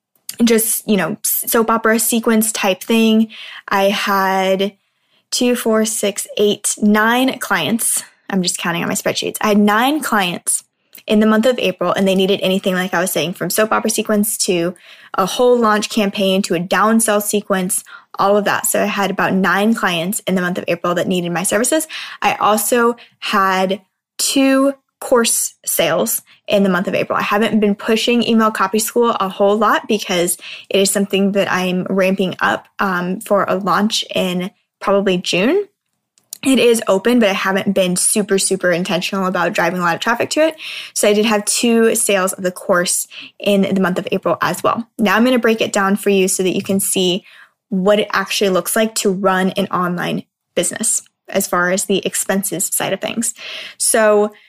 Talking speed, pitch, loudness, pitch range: 190 wpm, 200 Hz, -16 LUFS, 190-225 Hz